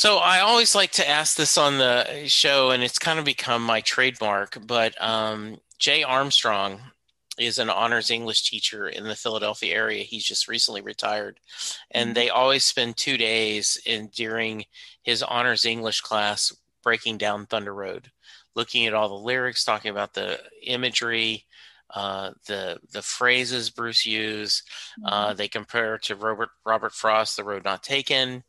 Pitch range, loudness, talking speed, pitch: 110-130 Hz, -22 LUFS, 160 wpm, 115 Hz